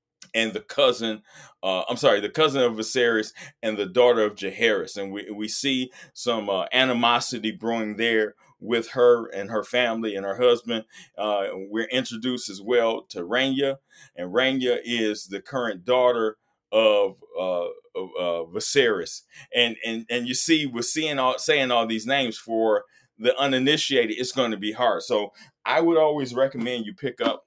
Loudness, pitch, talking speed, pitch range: -24 LUFS, 120 Hz, 170 wpm, 110-130 Hz